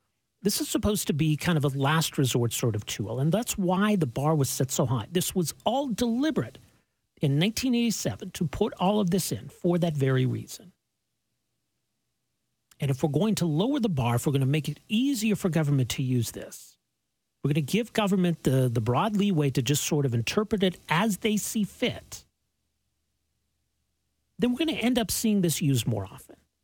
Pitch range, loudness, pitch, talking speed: 125-205 Hz, -26 LUFS, 155 Hz, 200 wpm